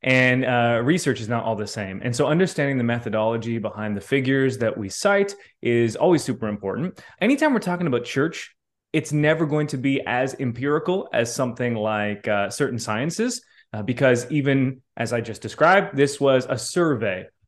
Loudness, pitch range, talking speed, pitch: -22 LUFS, 115-150 Hz, 180 wpm, 130 Hz